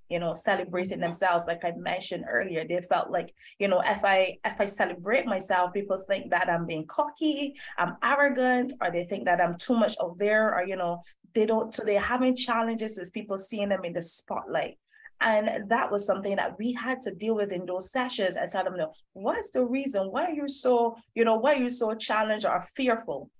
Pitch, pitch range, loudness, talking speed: 210 Hz, 180-245 Hz, -28 LUFS, 220 wpm